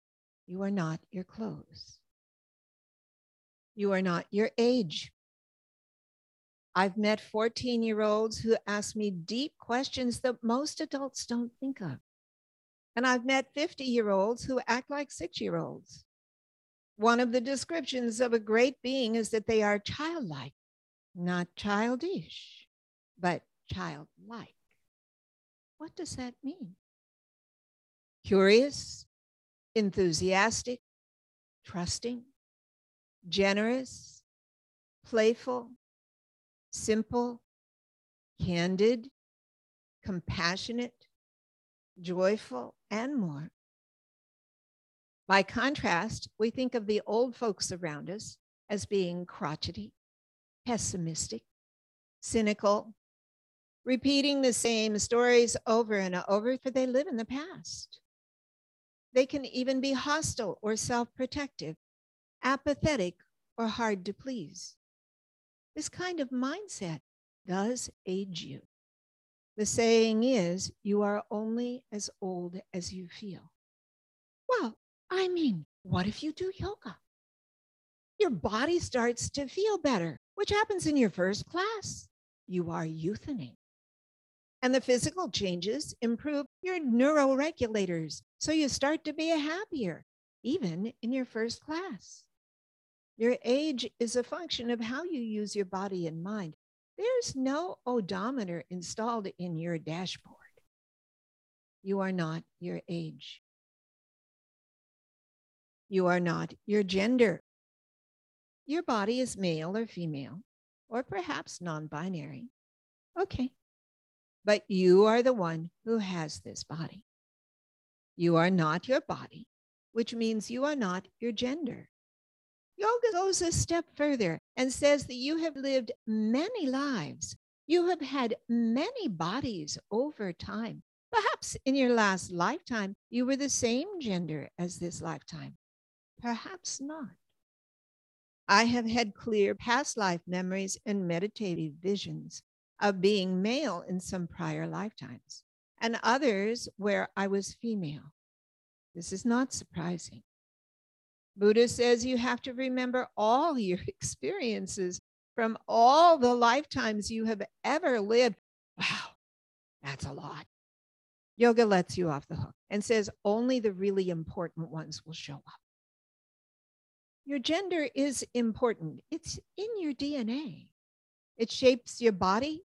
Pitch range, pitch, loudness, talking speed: 185-260 Hz, 225 Hz, -31 LUFS, 120 wpm